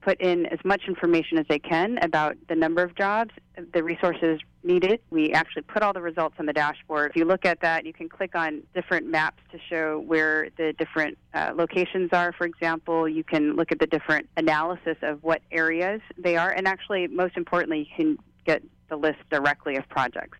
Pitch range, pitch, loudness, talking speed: 155-180 Hz, 165 Hz, -25 LUFS, 205 wpm